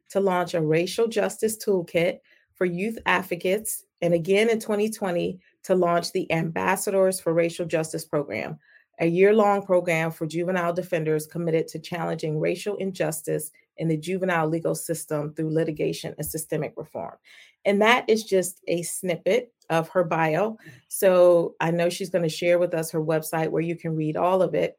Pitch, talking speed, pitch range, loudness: 175 Hz, 165 wpm, 165-190 Hz, -24 LUFS